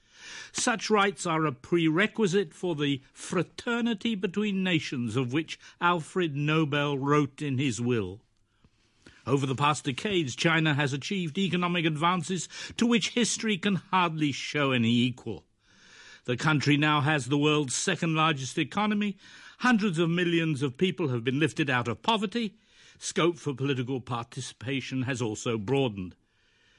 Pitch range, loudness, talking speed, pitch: 135-185 Hz, -28 LUFS, 140 wpm, 155 Hz